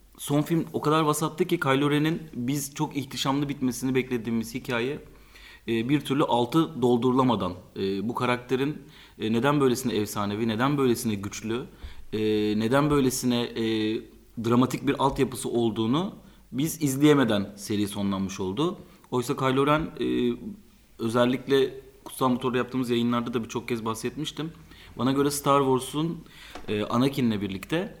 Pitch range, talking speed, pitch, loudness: 115-145 Hz, 120 wpm, 125 Hz, -26 LUFS